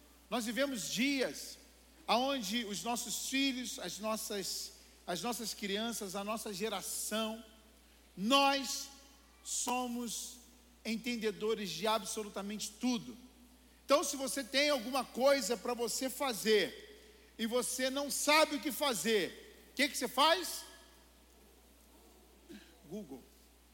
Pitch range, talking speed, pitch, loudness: 220-275 Hz, 110 wpm, 245 Hz, -35 LUFS